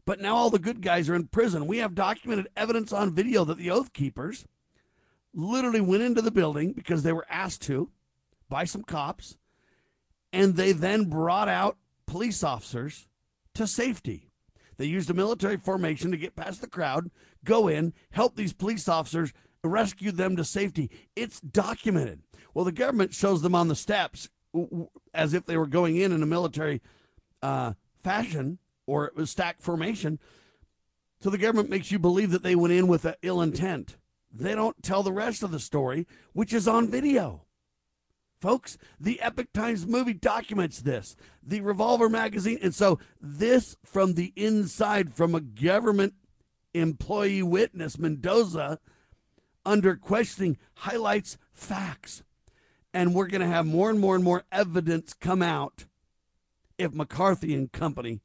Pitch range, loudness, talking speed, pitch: 160-210 Hz, -27 LUFS, 160 wpm, 185 Hz